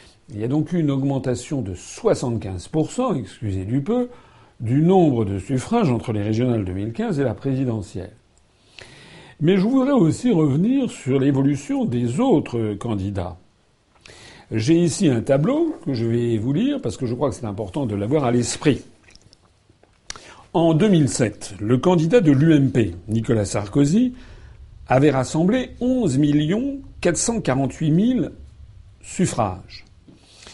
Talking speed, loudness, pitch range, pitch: 130 wpm, -20 LUFS, 110-165 Hz, 130 Hz